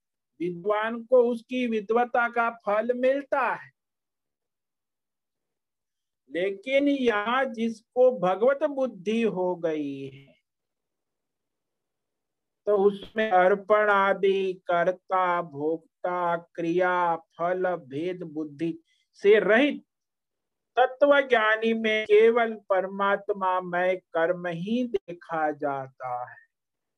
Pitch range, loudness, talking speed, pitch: 175-235 Hz, -25 LUFS, 85 wpm, 200 Hz